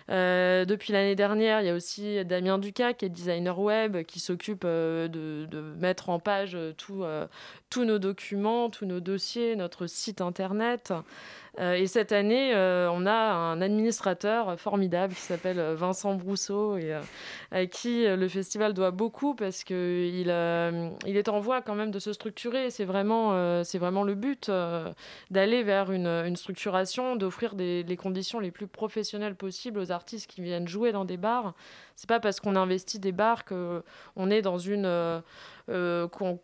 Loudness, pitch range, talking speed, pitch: -29 LUFS, 180-215 Hz, 180 wpm, 195 Hz